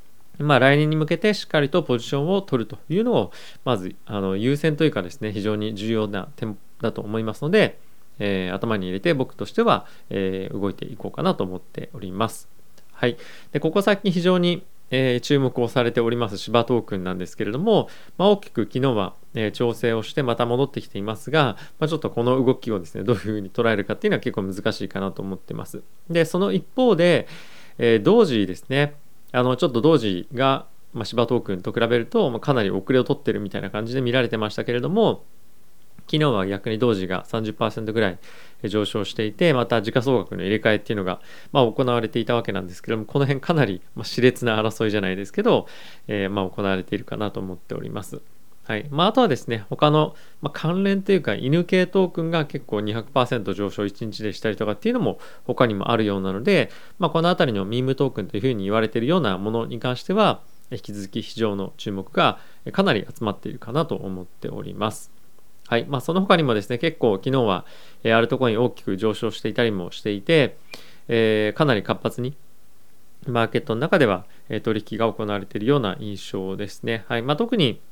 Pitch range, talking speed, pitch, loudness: 105-140 Hz, 405 characters per minute, 115 Hz, -23 LUFS